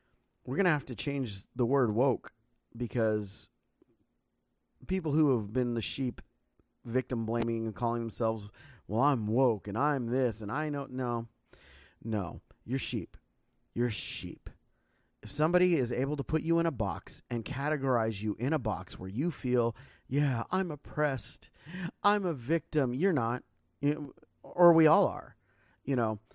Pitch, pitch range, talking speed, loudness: 125 Hz, 110-150 Hz, 155 wpm, -31 LUFS